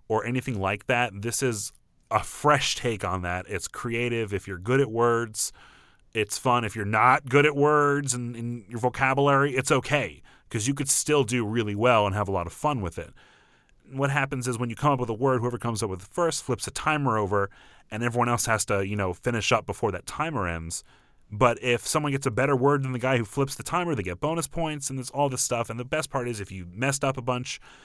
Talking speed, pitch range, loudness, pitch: 245 wpm, 110-140 Hz, -26 LUFS, 125 Hz